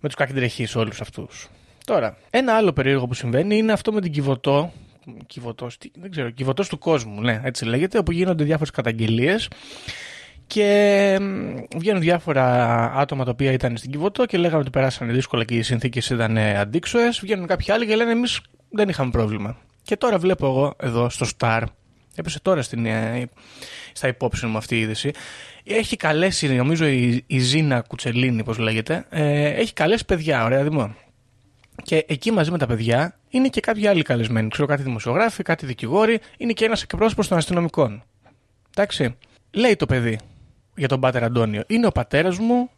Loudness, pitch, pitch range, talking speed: -21 LUFS, 140 Hz, 120-185 Hz, 170 wpm